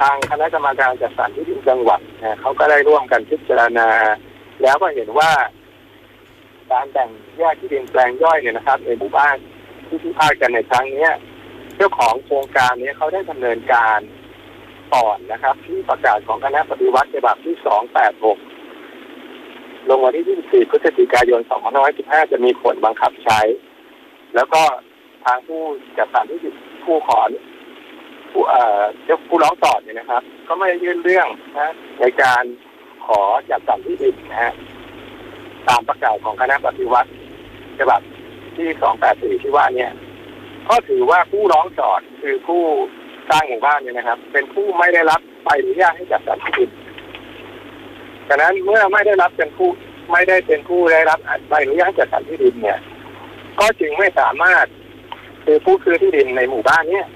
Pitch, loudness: 340 Hz, -16 LUFS